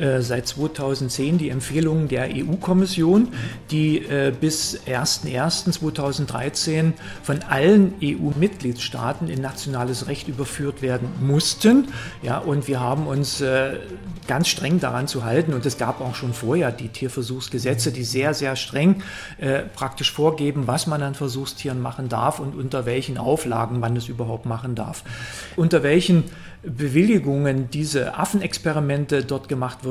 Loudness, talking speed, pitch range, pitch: -22 LUFS, 135 wpm, 130-155 Hz, 140 Hz